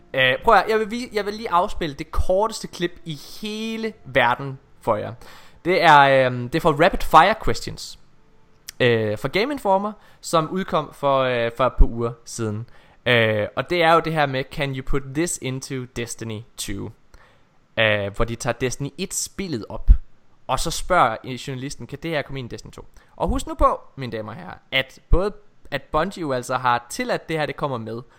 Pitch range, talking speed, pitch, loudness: 120-175 Hz, 200 wpm, 140 Hz, -22 LUFS